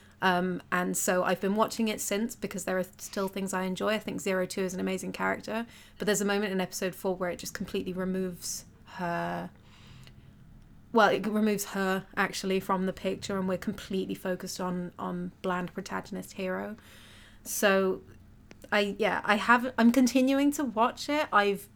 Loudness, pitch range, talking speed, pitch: -29 LUFS, 180-210 Hz, 175 wpm, 190 Hz